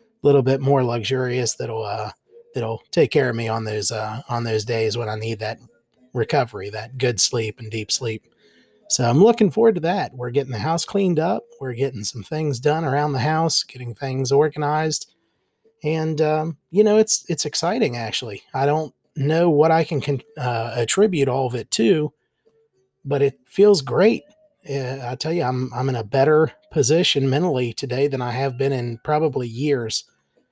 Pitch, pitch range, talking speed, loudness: 140 Hz, 120-160 Hz, 185 wpm, -21 LUFS